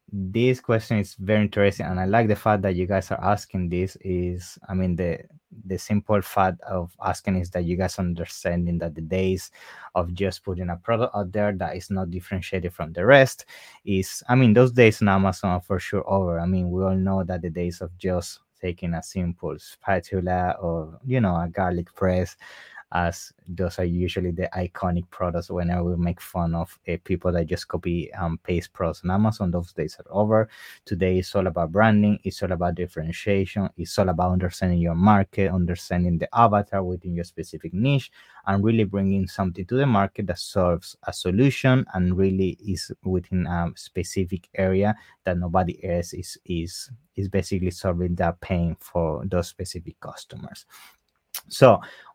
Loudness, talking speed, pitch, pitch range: -24 LUFS, 185 wpm, 95 Hz, 90-100 Hz